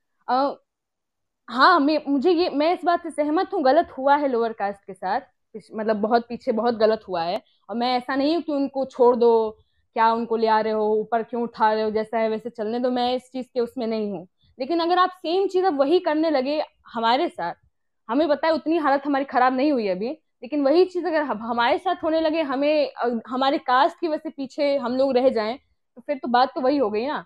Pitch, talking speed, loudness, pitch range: 260 Hz, 235 wpm, -22 LUFS, 230-305 Hz